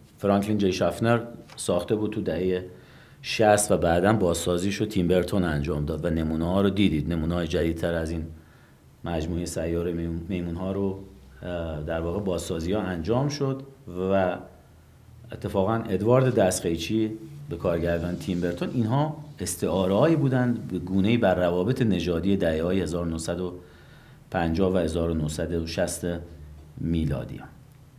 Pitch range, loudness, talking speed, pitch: 85-105 Hz, -26 LUFS, 125 wpm, 90 Hz